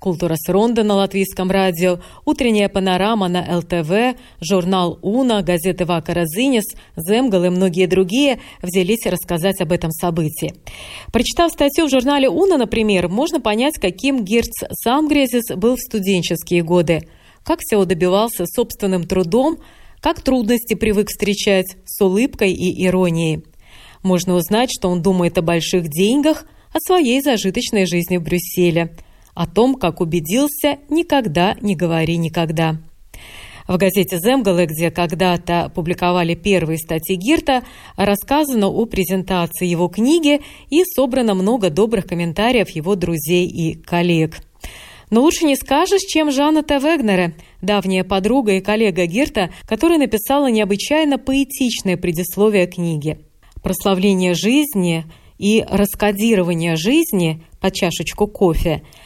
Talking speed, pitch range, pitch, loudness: 125 wpm, 175-245 Hz, 195 Hz, -17 LUFS